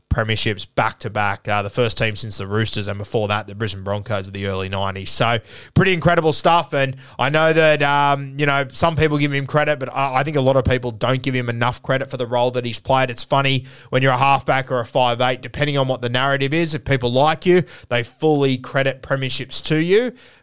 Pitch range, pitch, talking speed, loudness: 115-145 Hz, 130 Hz, 235 wpm, -19 LUFS